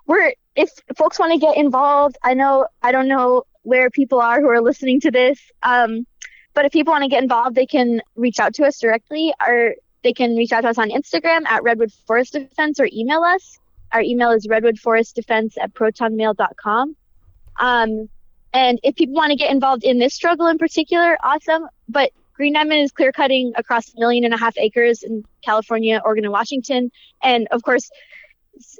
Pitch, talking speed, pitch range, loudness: 255 Hz, 195 wpm, 230-290 Hz, -17 LUFS